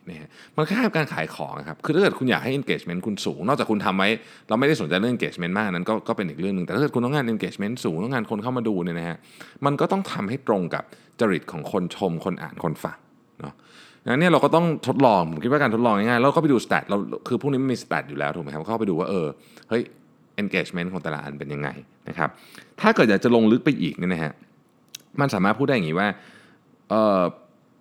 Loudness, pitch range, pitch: -23 LUFS, 85-145 Hz, 115 Hz